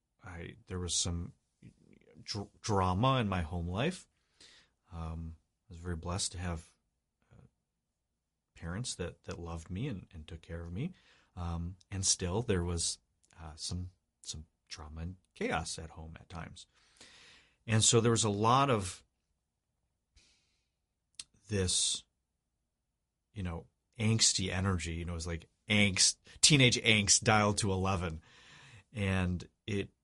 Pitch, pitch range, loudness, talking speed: 90 Hz, 85-105 Hz, -32 LUFS, 140 wpm